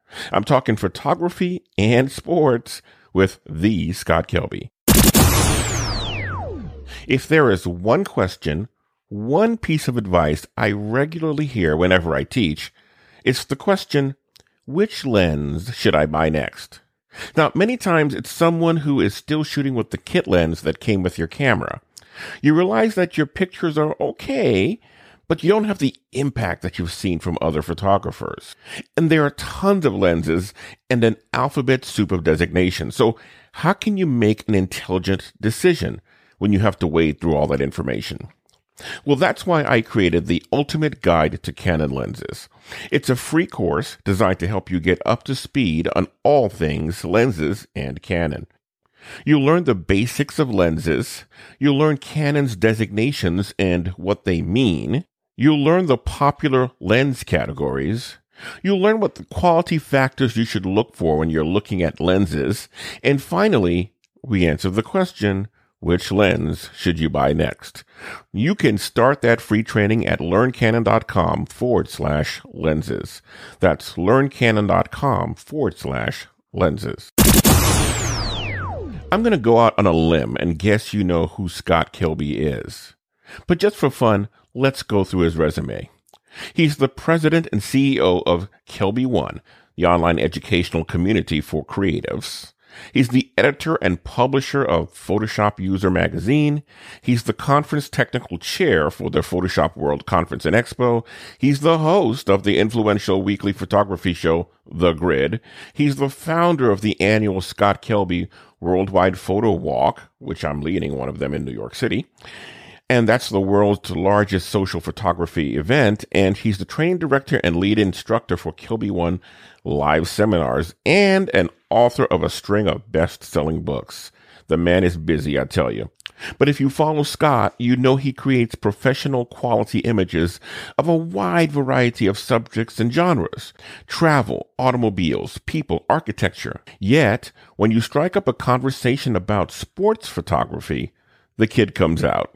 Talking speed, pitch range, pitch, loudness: 150 wpm, 90-135 Hz, 105 Hz, -19 LUFS